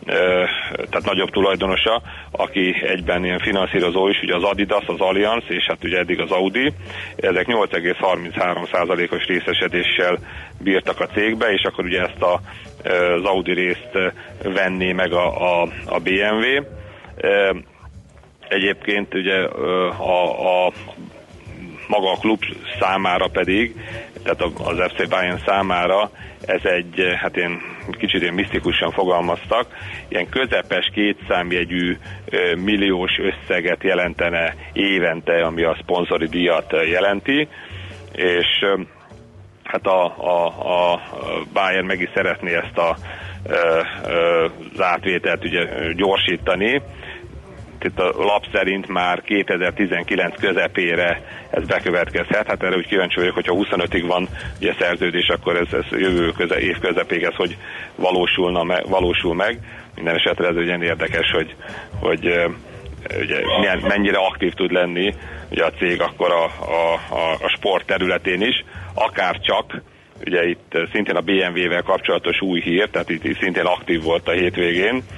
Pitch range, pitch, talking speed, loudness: 85-95 Hz, 90 Hz, 125 wpm, -19 LUFS